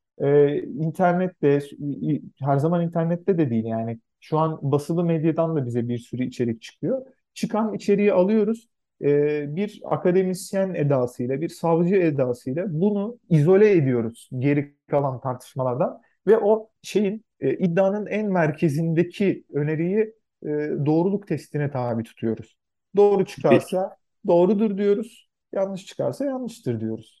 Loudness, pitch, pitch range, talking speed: -23 LUFS, 165 Hz, 140-195 Hz, 120 wpm